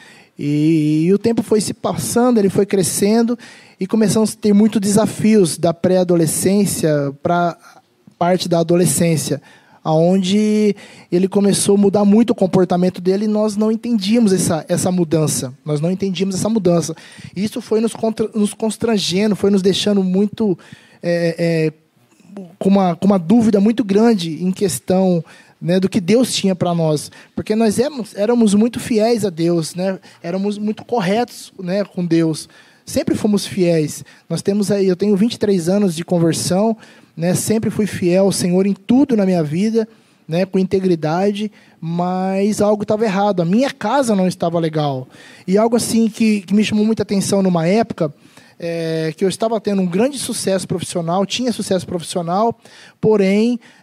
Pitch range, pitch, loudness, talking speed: 175-215 Hz, 195 Hz, -17 LUFS, 165 wpm